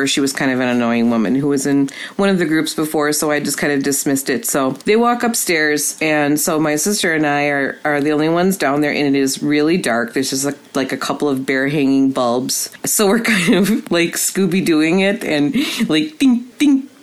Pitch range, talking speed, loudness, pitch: 140-190 Hz, 235 wpm, -16 LUFS, 150 Hz